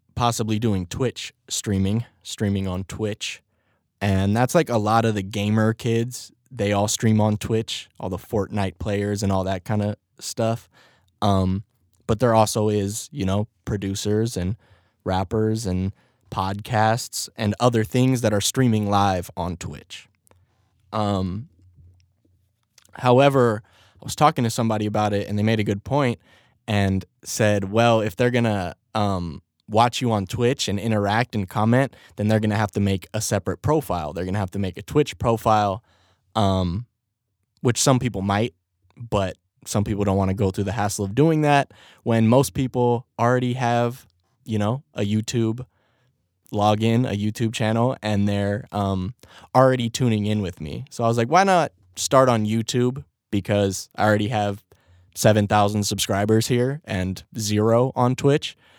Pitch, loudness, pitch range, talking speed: 105 Hz, -22 LUFS, 100-120 Hz, 165 wpm